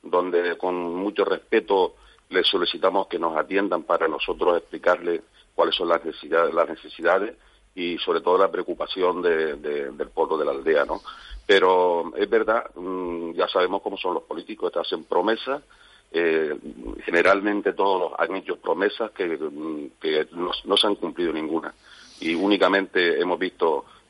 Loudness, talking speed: -23 LUFS, 150 wpm